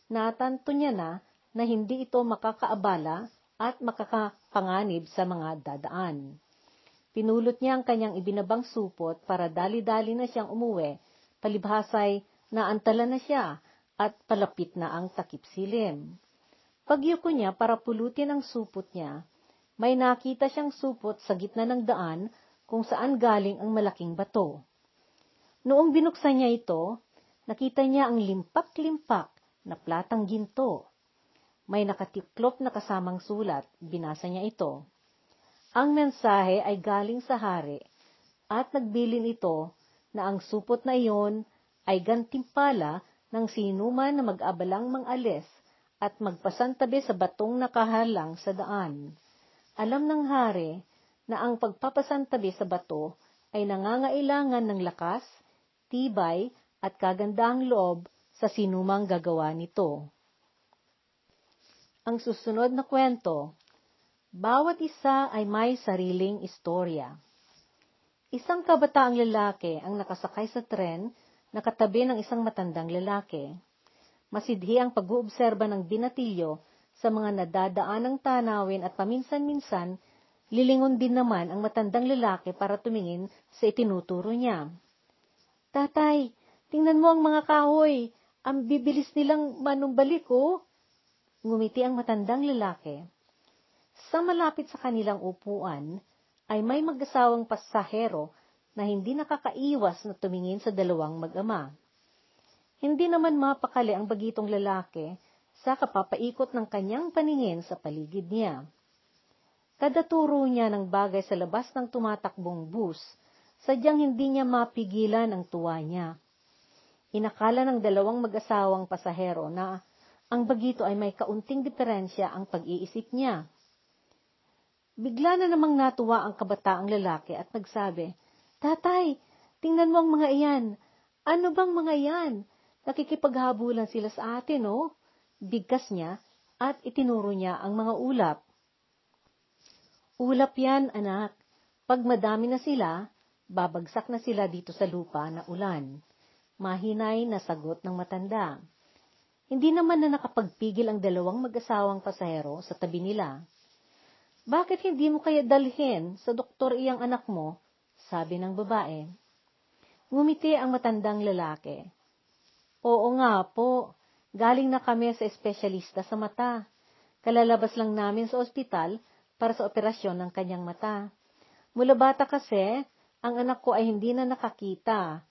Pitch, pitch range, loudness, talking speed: 220 Hz, 190-255 Hz, -28 LUFS, 120 wpm